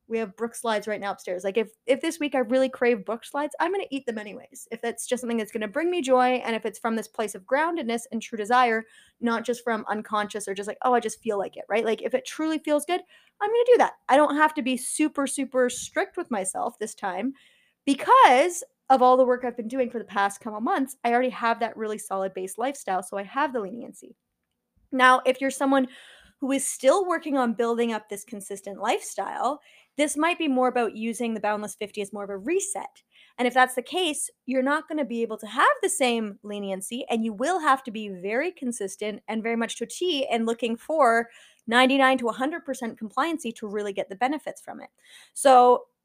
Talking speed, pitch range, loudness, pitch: 235 wpm, 220-275 Hz, -25 LUFS, 245 Hz